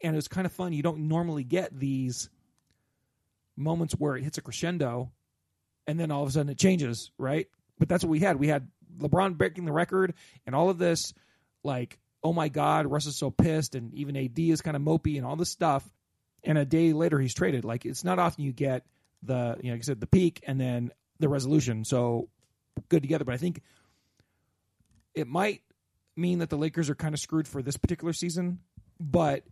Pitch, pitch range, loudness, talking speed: 150 Hz, 135-170 Hz, -29 LUFS, 215 wpm